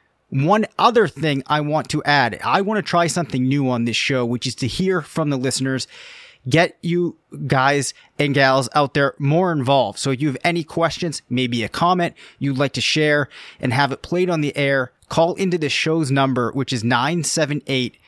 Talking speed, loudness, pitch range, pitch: 200 wpm, -19 LUFS, 130-165 Hz, 145 Hz